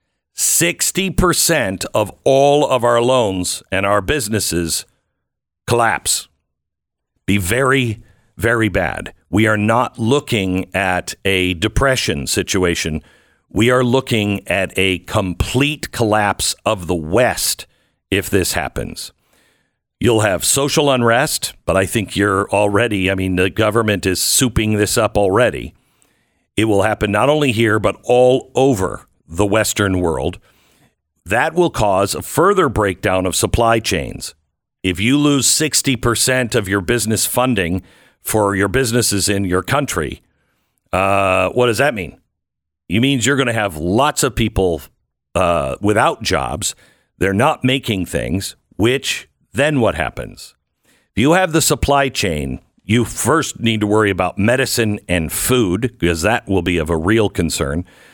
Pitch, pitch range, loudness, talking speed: 105 Hz, 95-125 Hz, -16 LUFS, 140 wpm